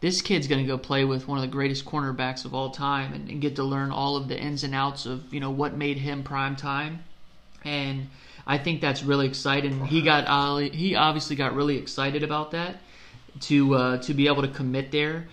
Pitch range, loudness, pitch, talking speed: 135-145 Hz, -26 LUFS, 140 Hz, 225 wpm